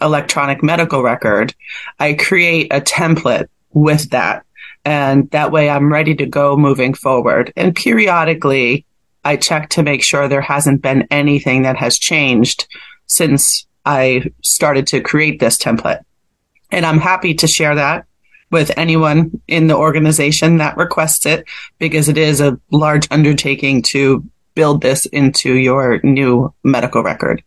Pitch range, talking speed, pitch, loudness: 140-160 Hz, 145 wpm, 145 Hz, -13 LUFS